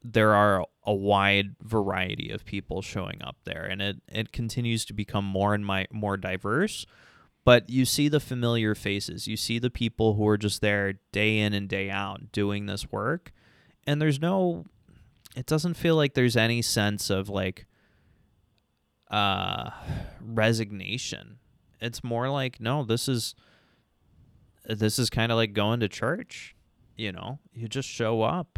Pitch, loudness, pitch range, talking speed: 110 Hz, -27 LUFS, 100-120 Hz, 160 wpm